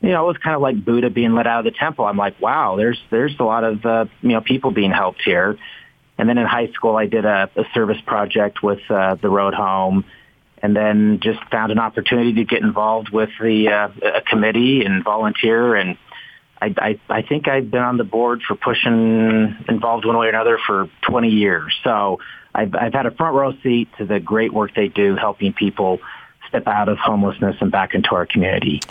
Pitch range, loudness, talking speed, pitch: 105-120 Hz, -18 LUFS, 220 wpm, 110 Hz